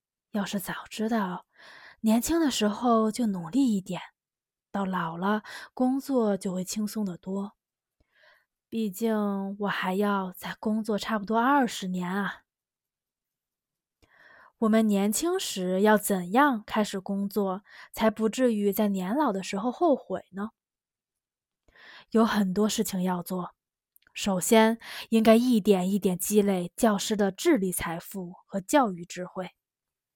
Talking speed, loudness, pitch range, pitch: 190 characters per minute, -27 LUFS, 190-225 Hz, 205 Hz